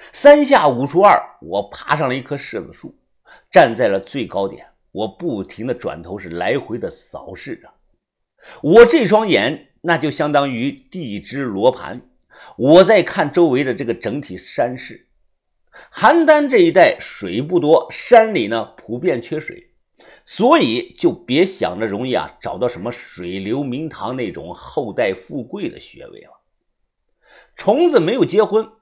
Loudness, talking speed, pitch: -16 LUFS, 220 characters per minute, 215 Hz